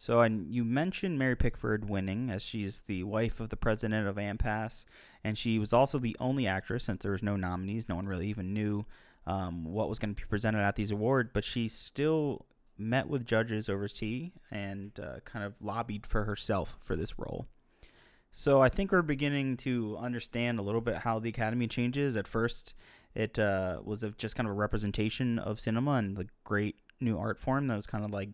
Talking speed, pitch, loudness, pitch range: 210 wpm, 110 Hz, -33 LUFS, 100-120 Hz